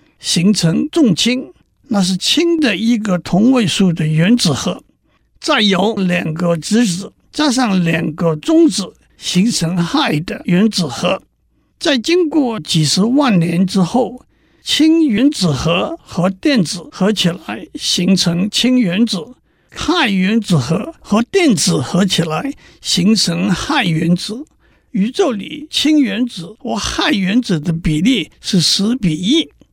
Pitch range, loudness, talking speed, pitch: 175-255 Hz, -15 LUFS, 190 characters per minute, 205 Hz